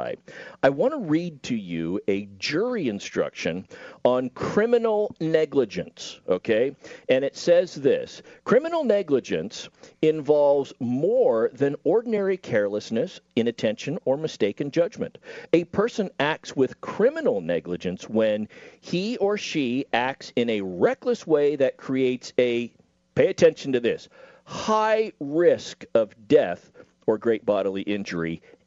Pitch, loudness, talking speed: 150 Hz, -24 LUFS, 120 wpm